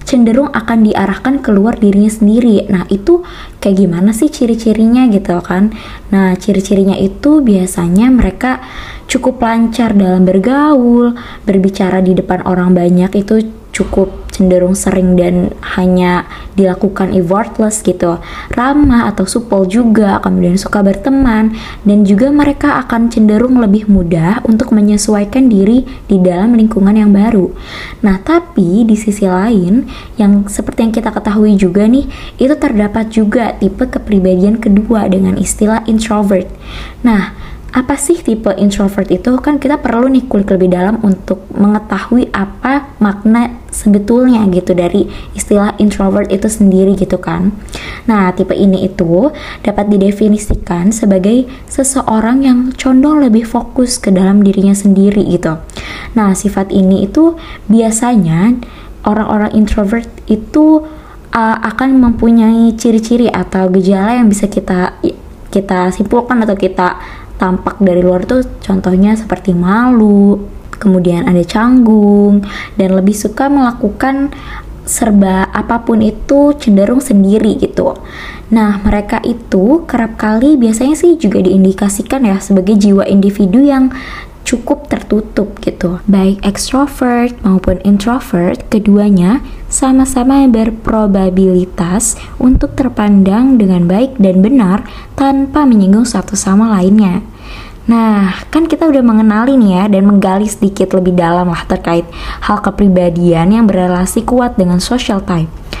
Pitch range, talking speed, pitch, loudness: 195-240 Hz, 125 wpm, 210 Hz, -10 LUFS